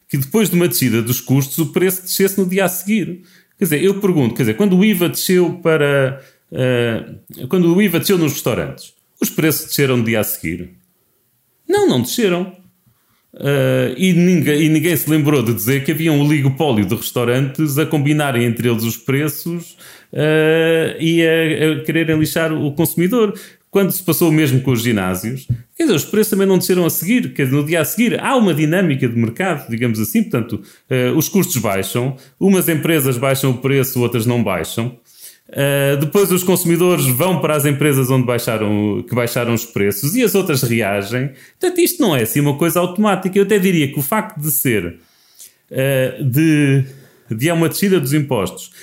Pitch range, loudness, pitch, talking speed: 125-175 Hz, -16 LUFS, 150 Hz, 195 wpm